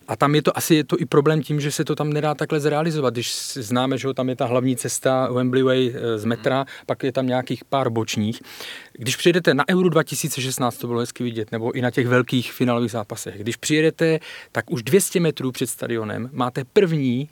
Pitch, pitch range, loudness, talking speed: 130 Hz, 125-150 Hz, -21 LUFS, 210 wpm